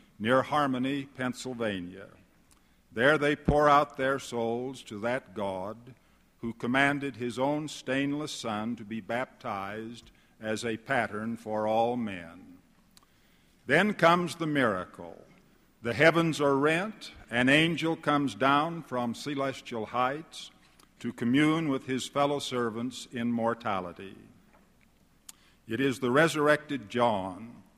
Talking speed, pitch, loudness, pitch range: 120 wpm, 130 Hz, -29 LUFS, 115-145 Hz